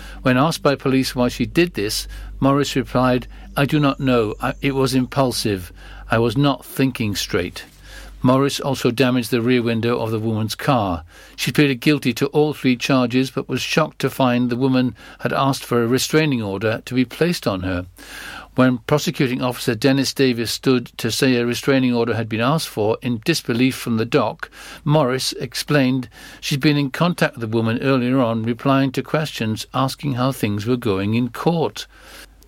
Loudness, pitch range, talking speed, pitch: -19 LUFS, 115-140 Hz, 185 wpm, 130 Hz